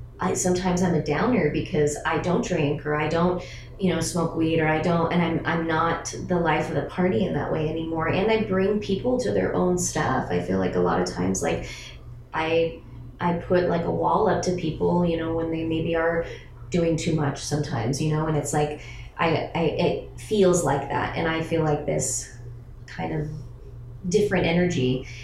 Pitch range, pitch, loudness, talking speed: 135-170 Hz, 160 Hz, -24 LUFS, 205 wpm